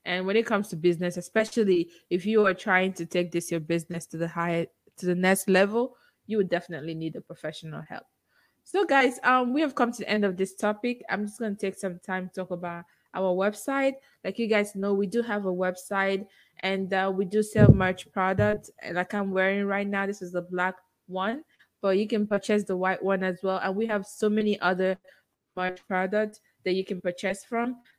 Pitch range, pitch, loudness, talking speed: 180-210 Hz, 195 Hz, -27 LUFS, 220 wpm